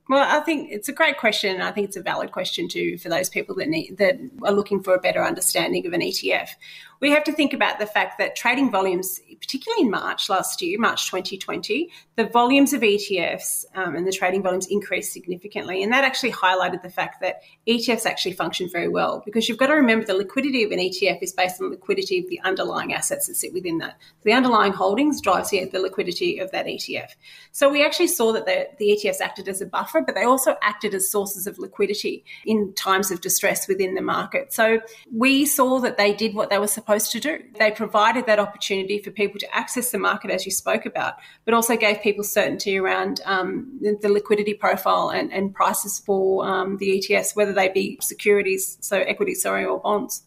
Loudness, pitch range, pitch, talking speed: -22 LUFS, 195-275 Hz, 210 Hz, 215 wpm